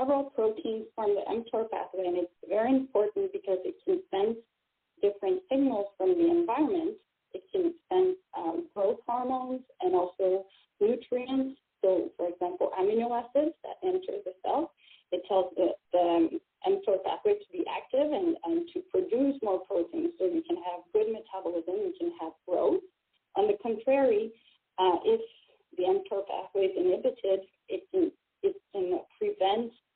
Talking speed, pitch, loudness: 155 wpm, 255 Hz, -30 LUFS